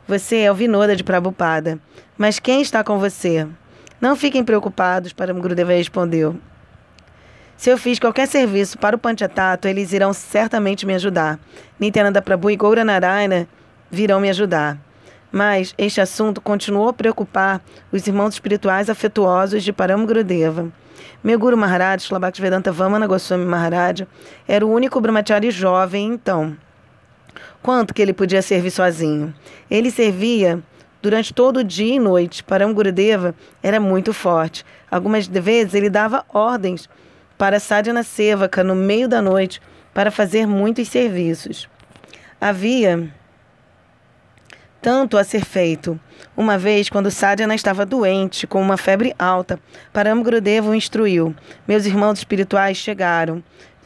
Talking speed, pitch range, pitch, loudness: 135 wpm, 185-215 Hz, 200 Hz, -17 LUFS